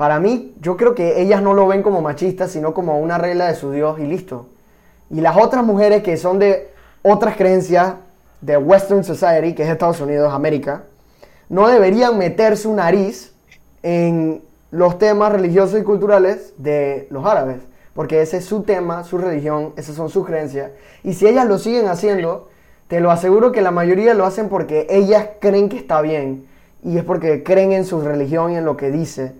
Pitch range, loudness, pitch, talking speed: 155-200 Hz, -16 LUFS, 180 Hz, 190 wpm